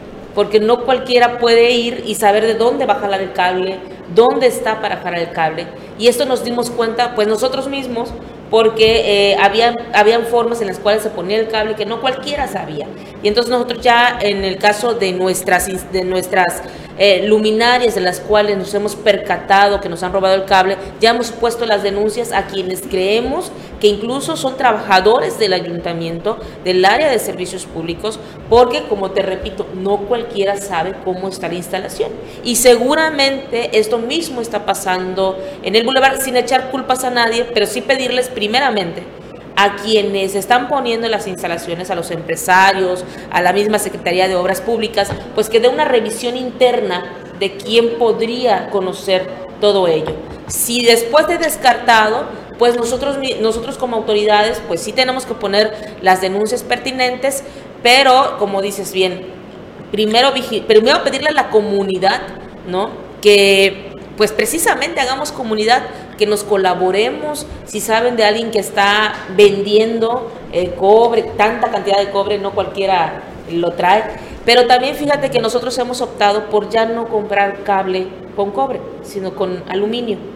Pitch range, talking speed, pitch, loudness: 195-240 Hz, 160 wpm, 210 Hz, -15 LUFS